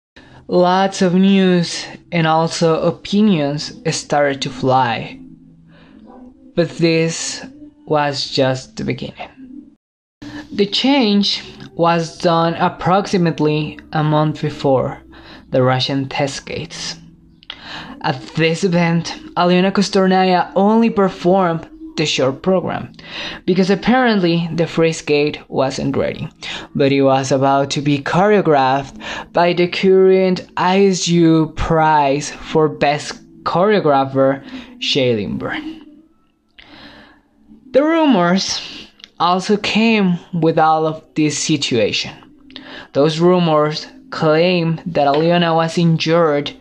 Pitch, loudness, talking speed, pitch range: 170 Hz, -16 LUFS, 100 wpm, 150-195 Hz